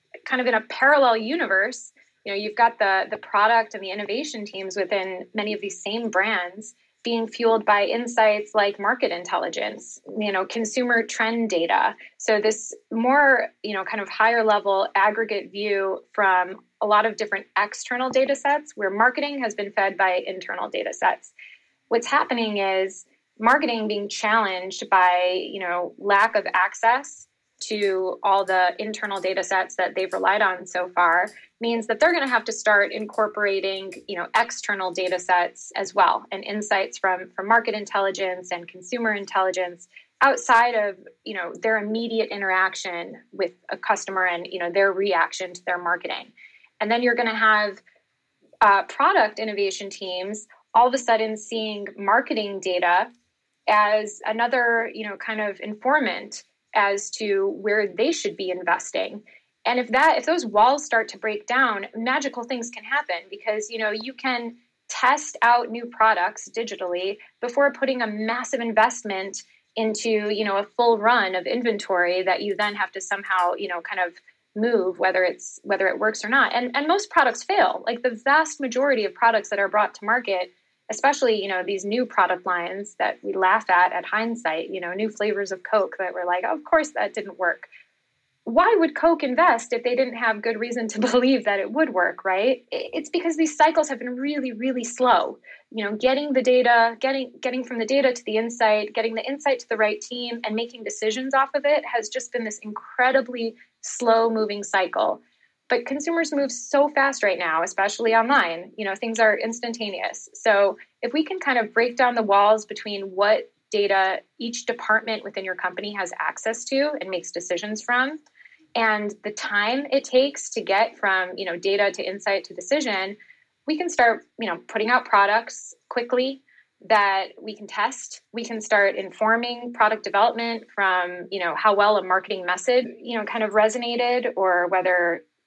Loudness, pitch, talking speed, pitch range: -22 LUFS, 220 Hz, 180 wpm, 195-245 Hz